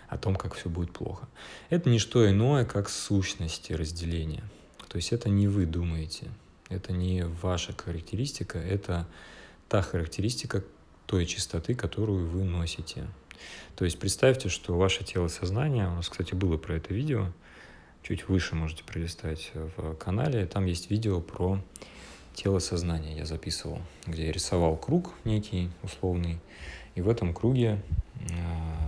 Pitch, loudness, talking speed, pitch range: 90 Hz, -30 LUFS, 145 wpm, 85-100 Hz